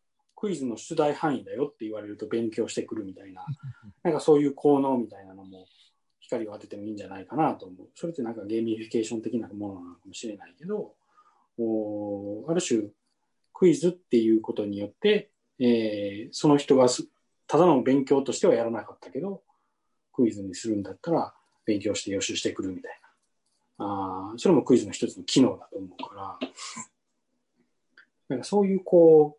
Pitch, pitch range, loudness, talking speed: 115 Hz, 105-150 Hz, -26 LUFS, 380 characters per minute